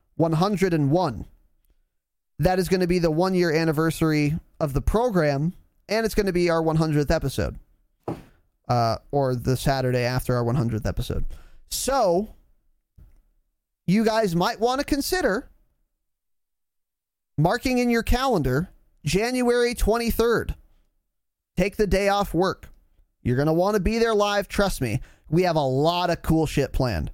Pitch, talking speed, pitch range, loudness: 160 Hz, 145 wpm, 125-200 Hz, -23 LUFS